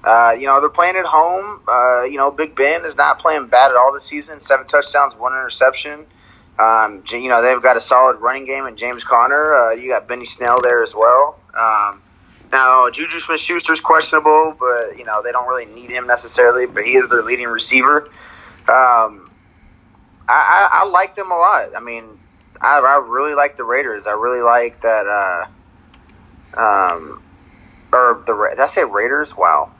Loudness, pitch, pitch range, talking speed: -14 LUFS, 130 Hz, 120-155 Hz, 190 wpm